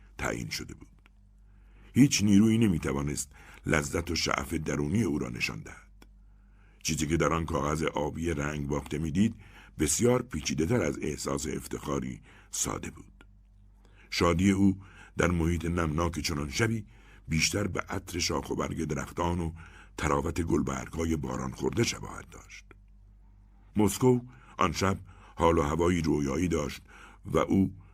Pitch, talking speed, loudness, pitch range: 90 Hz, 135 wpm, -29 LUFS, 75-100 Hz